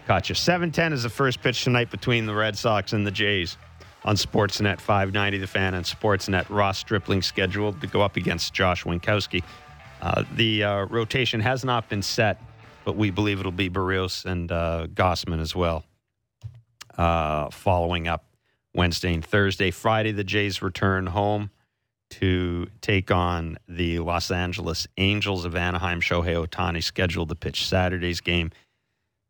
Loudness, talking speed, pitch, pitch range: -24 LUFS, 155 wpm, 95 Hz, 90-105 Hz